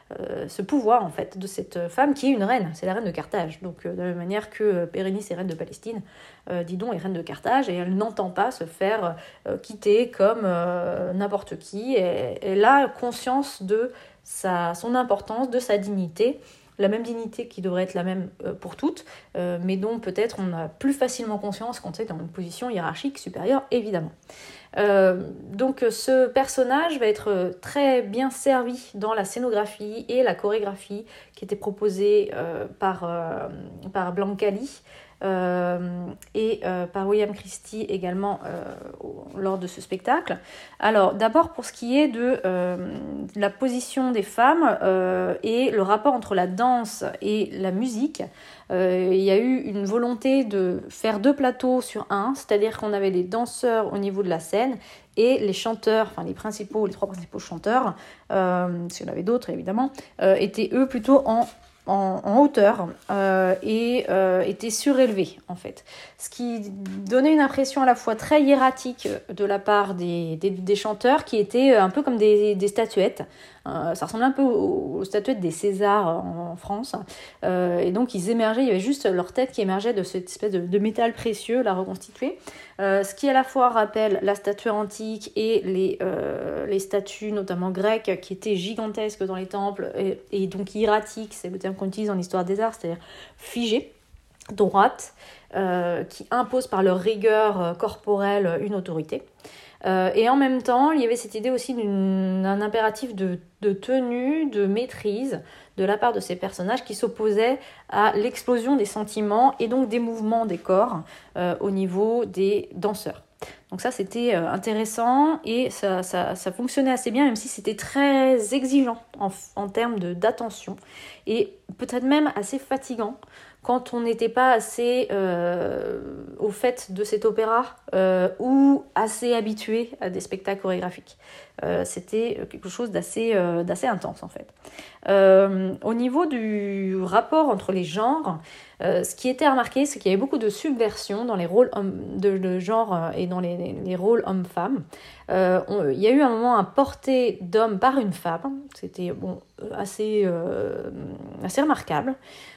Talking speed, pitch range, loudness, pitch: 175 wpm, 190-245 Hz, -24 LUFS, 210 Hz